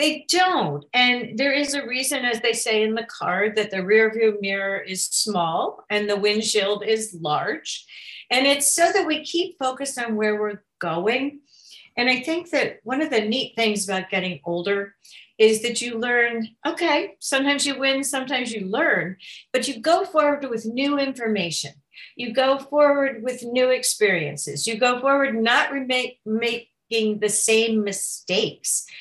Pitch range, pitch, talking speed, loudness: 210-275 Hz, 235 Hz, 170 wpm, -22 LUFS